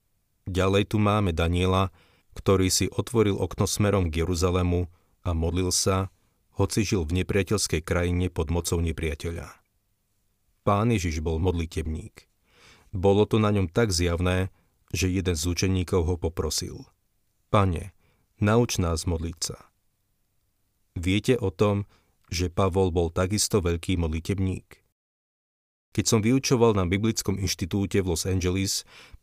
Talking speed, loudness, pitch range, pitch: 125 wpm, -25 LUFS, 85-100 Hz, 95 Hz